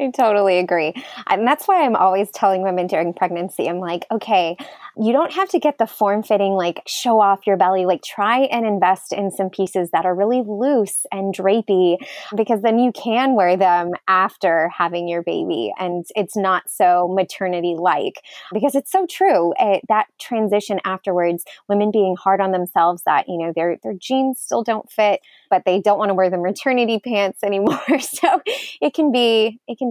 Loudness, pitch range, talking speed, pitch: -18 LUFS, 185-235 Hz, 190 wpm, 200 Hz